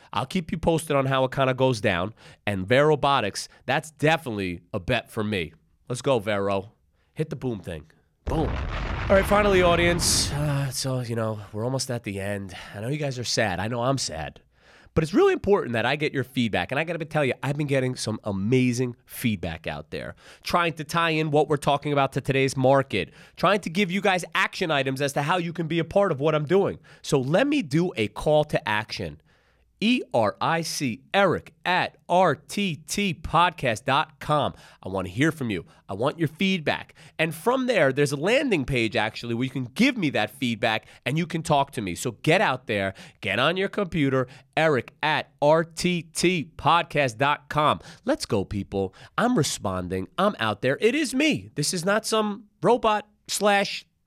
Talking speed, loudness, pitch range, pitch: 195 wpm, -24 LUFS, 115-170 Hz, 145 Hz